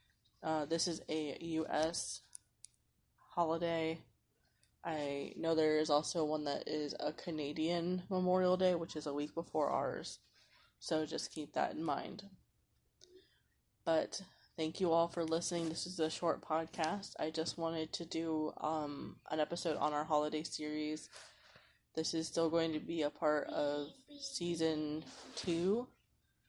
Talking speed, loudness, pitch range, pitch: 145 wpm, -38 LUFS, 150-170 Hz, 160 Hz